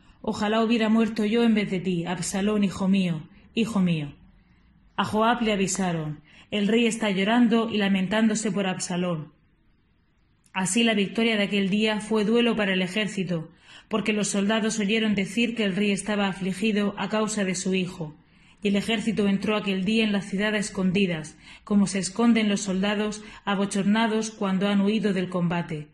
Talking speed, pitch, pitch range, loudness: 170 wpm, 205 Hz, 190-220 Hz, -25 LUFS